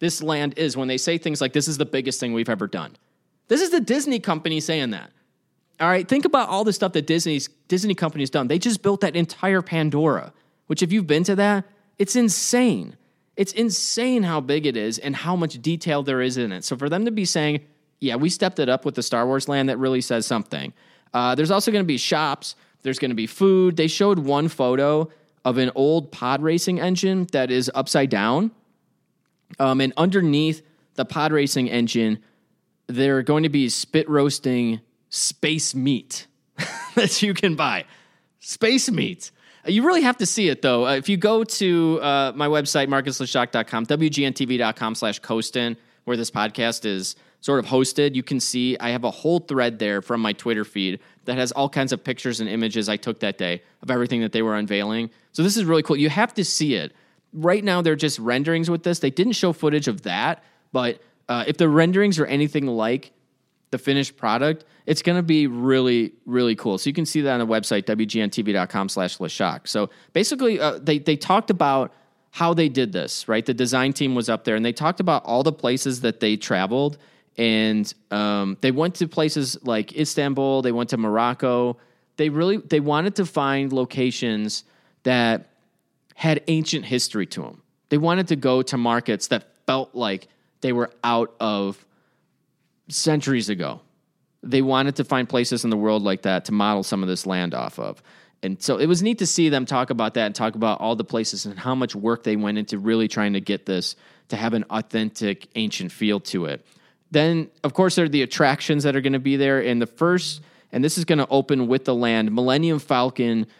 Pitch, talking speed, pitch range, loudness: 140 Hz, 205 wpm, 120-165 Hz, -22 LUFS